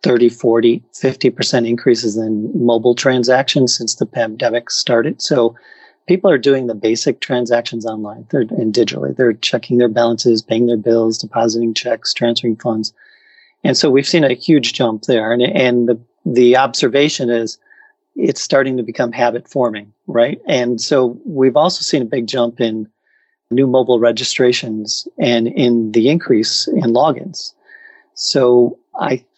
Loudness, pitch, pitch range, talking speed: -15 LUFS, 120 Hz, 115-130 Hz, 150 wpm